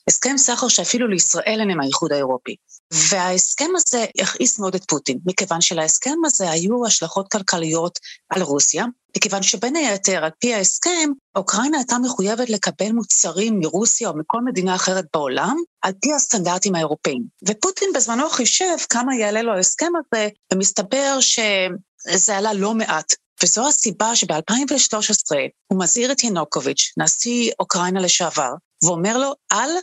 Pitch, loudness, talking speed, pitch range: 210 Hz, -18 LUFS, 135 wpm, 180-245 Hz